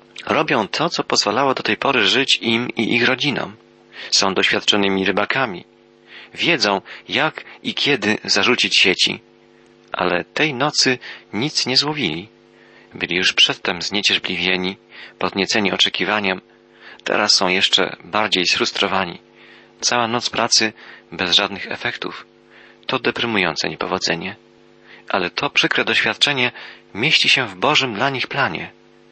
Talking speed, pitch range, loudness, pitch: 120 wpm, 90-115 Hz, -17 LUFS, 100 Hz